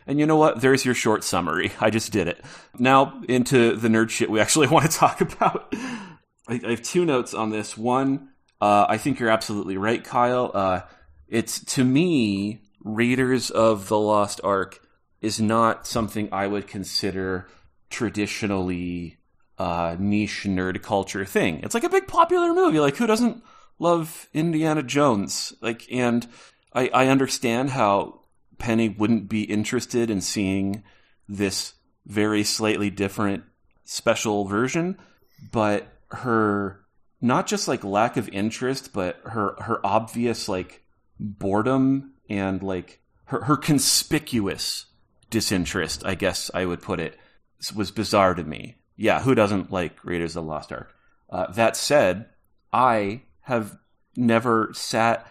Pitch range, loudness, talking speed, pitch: 100-125 Hz, -23 LUFS, 145 wpm, 110 Hz